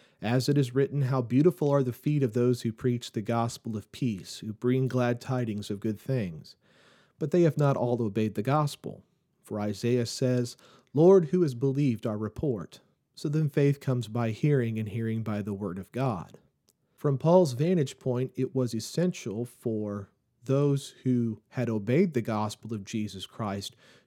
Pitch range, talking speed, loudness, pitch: 110-140 Hz, 175 wpm, -28 LUFS, 125 Hz